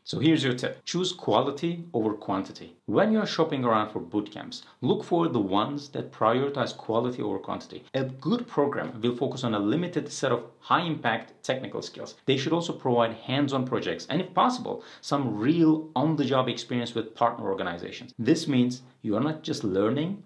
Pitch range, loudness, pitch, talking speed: 120-160 Hz, -27 LUFS, 140 Hz, 195 wpm